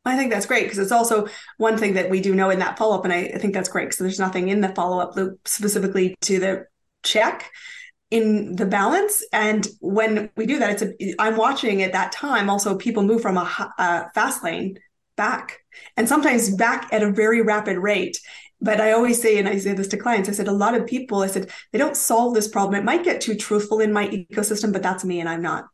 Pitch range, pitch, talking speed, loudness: 195-225 Hz, 210 Hz, 245 wpm, -21 LUFS